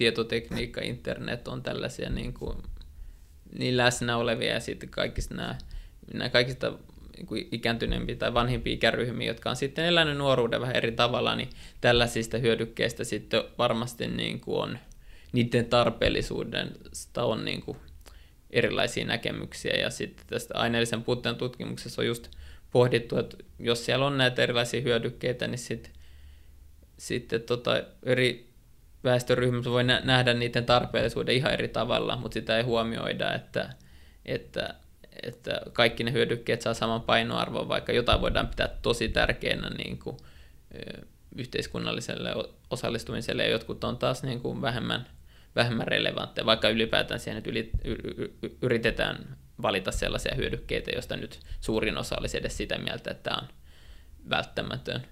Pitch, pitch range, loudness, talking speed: 115 Hz, 70-120 Hz, -28 LUFS, 135 wpm